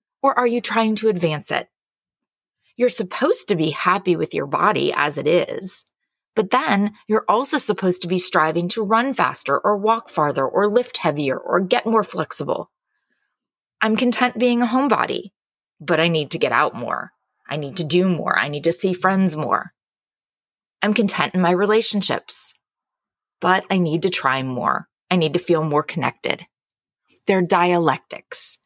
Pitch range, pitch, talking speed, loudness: 165-220 Hz, 185 Hz, 170 wpm, -19 LUFS